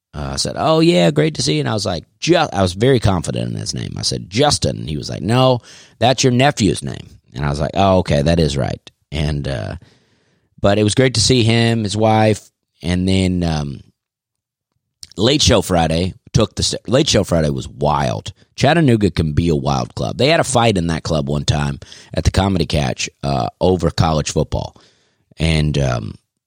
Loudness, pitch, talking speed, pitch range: -17 LUFS, 95 Hz, 205 wpm, 80-120 Hz